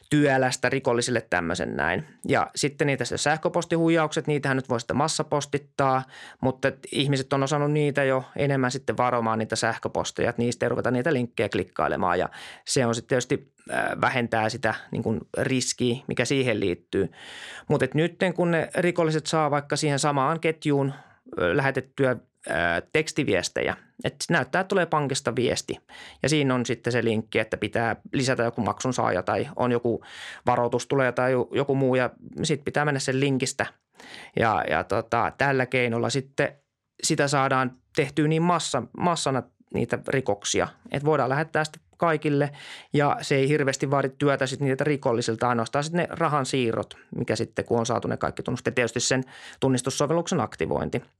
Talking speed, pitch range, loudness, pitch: 155 wpm, 125-150 Hz, -25 LUFS, 135 Hz